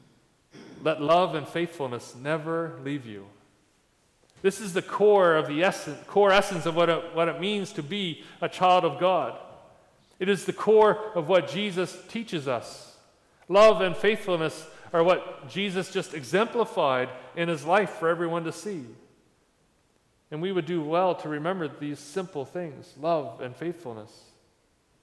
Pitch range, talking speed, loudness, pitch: 155-190 Hz, 155 wpm, -26 LUFS, 170 Hz